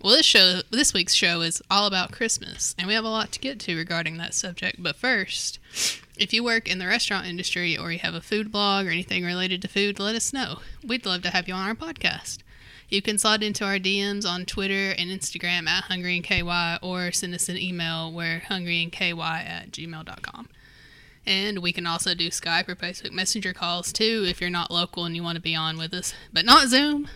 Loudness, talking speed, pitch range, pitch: -23 LUFS, 215 wpm, 175-205 Hz, 185 Hz